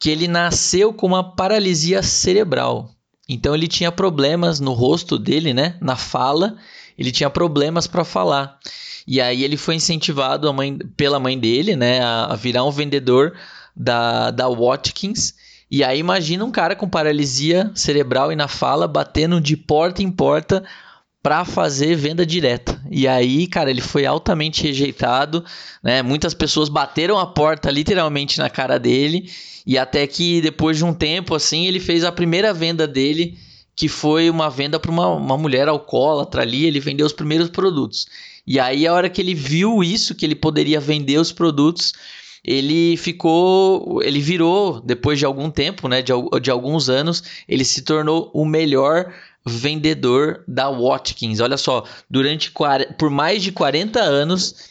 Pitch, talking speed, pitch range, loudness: 155 Hz, 160 wpm, 140-170 Hz, -18 LUFS